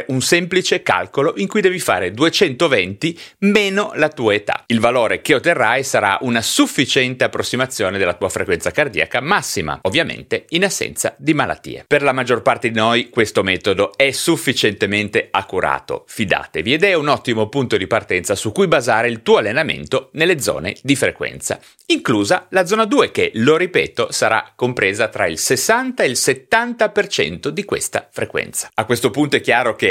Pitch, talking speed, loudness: 190 Hz, 165 wpm, -17 LUFS